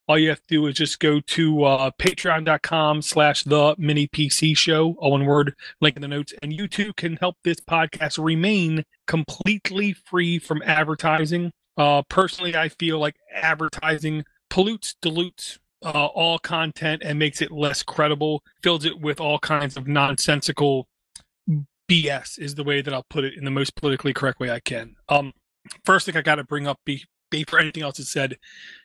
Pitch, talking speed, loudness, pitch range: 155 Hz, 185 wpm, -22 LUFS, 145-165 Hz